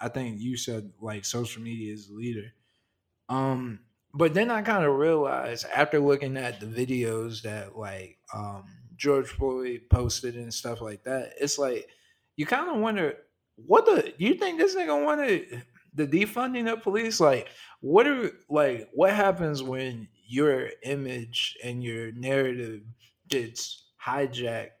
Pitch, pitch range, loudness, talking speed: 125 Hz, 115-160 Hz, -27 LUFS, 150 wpm